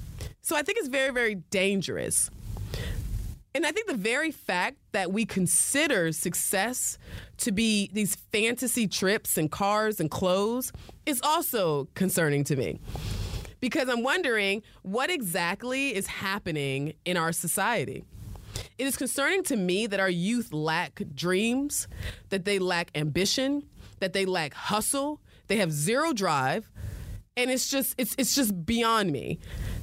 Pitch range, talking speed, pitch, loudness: 160-250 Hz, 145 wpm, 195 Hz, -27 LUFS